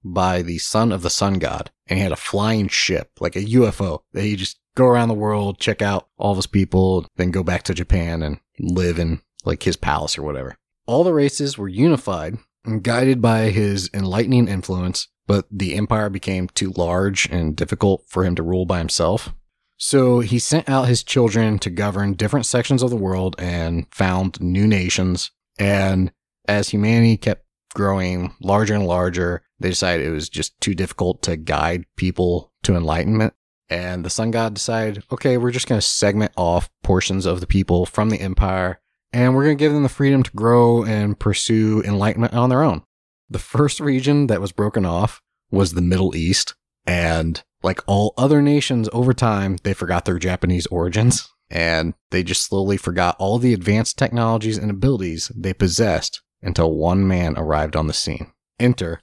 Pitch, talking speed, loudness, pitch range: 100 Hz, 185 wpm, -19 LUFS, 90-115 Hz